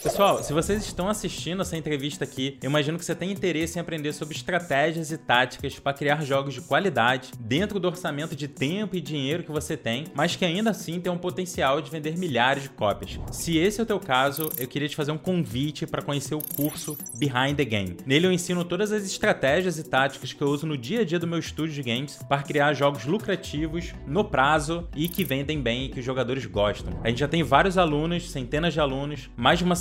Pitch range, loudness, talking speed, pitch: 135-175 Hz, -26 LUFS, 230 wpm, 150 Hz